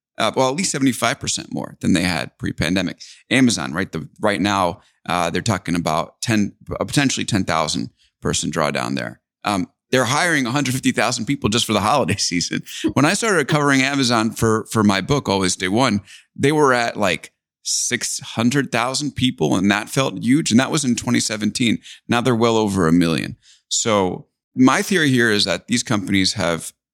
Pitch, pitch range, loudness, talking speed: 115 Hz, 95-130 Hz, -19 LUFS, 190 wpm